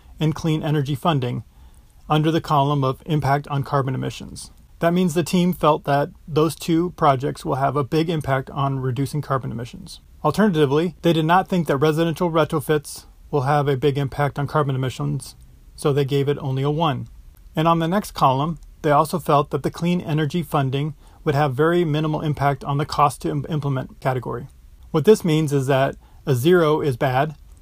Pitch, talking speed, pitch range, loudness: 150 Hz, 190 wpm, 140-160 Hz, -21 LUFS